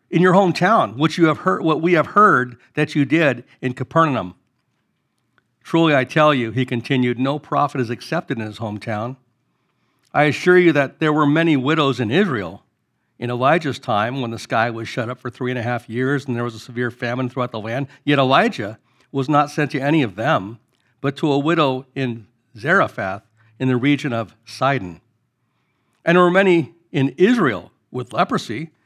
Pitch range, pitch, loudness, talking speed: 120-150 Hz, 130 Hz, -19 LUFS, 190 wpm